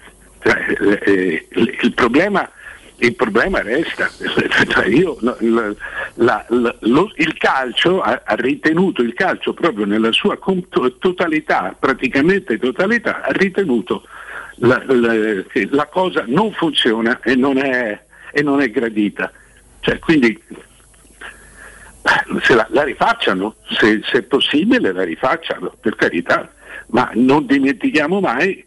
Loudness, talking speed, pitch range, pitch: -16 LUFS, 120 wpm, 115-185 Hz, 135 Hz